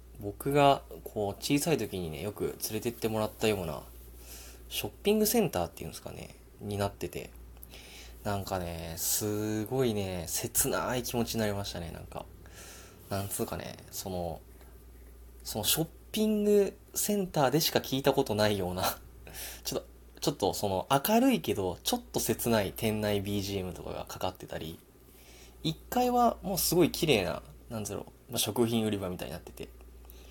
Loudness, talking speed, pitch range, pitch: -31 LUFS, 340 characters per minute, 80-125 Hz, 100 Hz